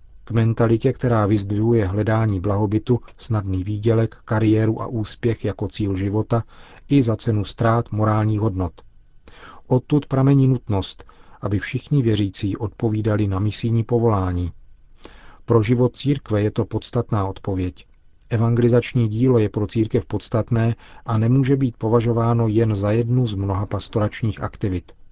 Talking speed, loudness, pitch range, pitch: 125 wpm, -21 LUFS, 105-120 Hz, 110 Hz